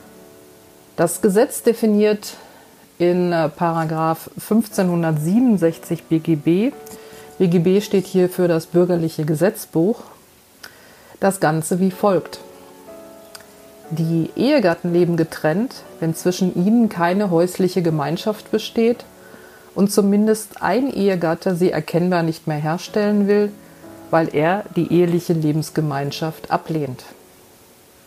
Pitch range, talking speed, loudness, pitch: 160-200 Hz, 95 wpm, -19 LUFS, 175 Hz